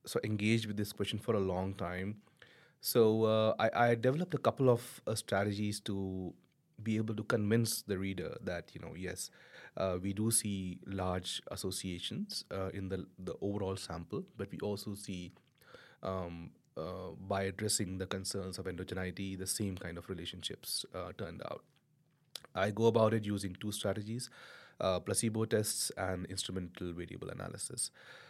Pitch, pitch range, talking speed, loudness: 100 Hz, 95-110 Hz, 160 wpm, -36 LUFS